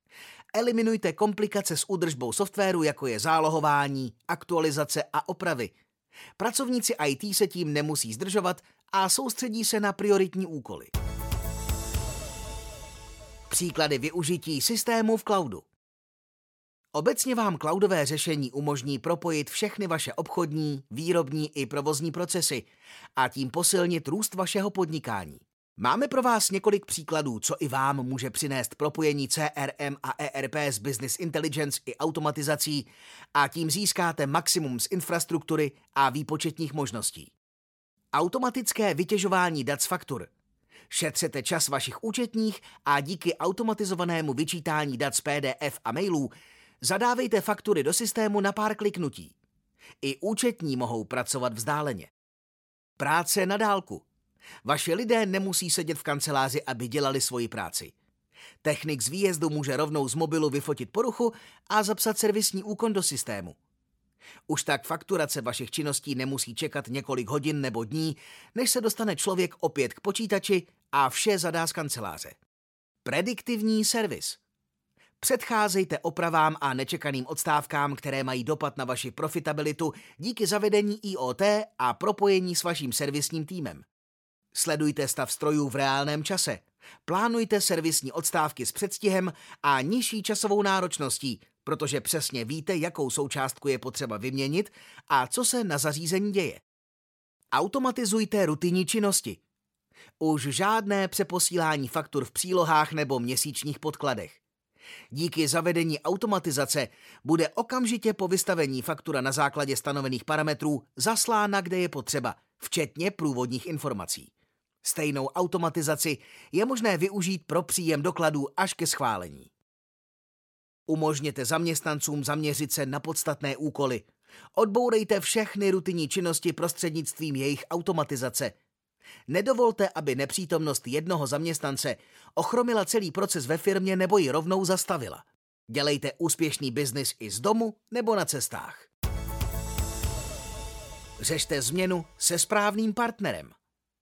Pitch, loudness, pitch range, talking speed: 160 Hz, -28 LUFS, 140-195 Hz, 120 wpm